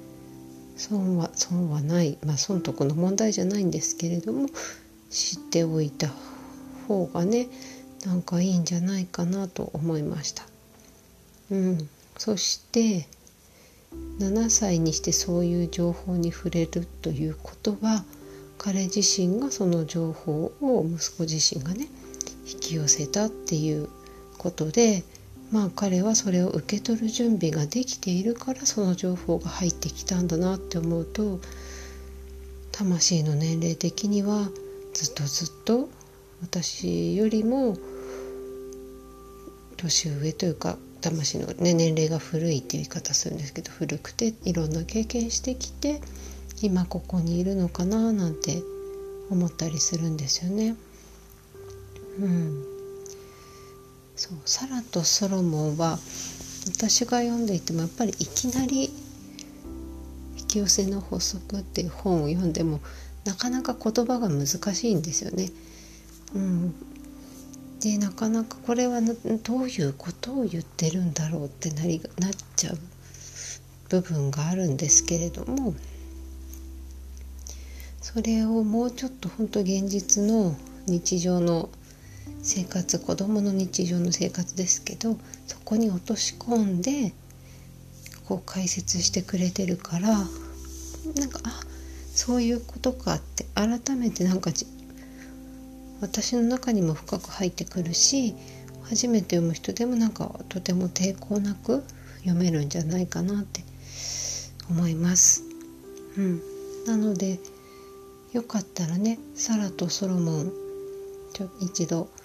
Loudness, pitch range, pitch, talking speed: -26 LUFS, 155-215 Hz, 180 Hz, 250 characters per minute